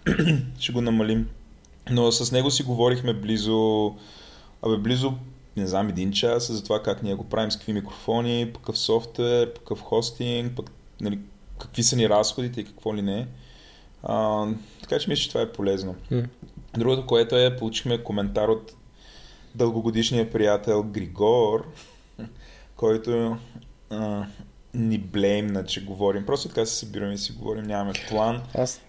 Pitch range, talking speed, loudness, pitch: 105-120 Hz, 145 wpm, -25 LUFS, 110 Hz